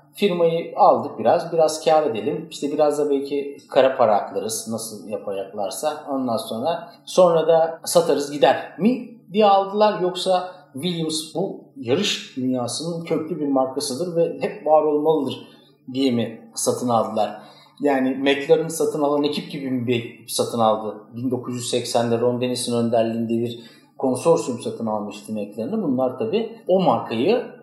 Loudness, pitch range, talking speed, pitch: -21 LUFS, 120-165 Hz, 135 wpm, 145 Hz